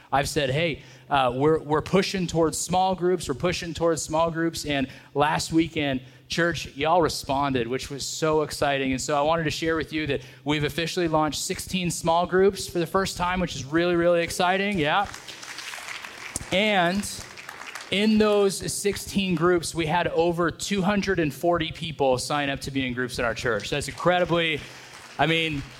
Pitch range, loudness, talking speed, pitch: 140-175 Hz, -24 LUFS, 170 wpm, 165 Hz